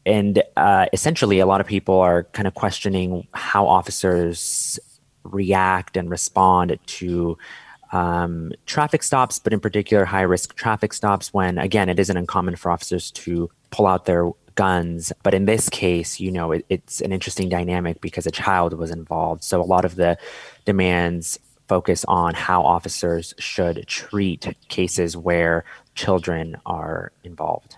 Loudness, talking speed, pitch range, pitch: -21 LUFS, 155 wpm, 85-100 Hz, 90 Hz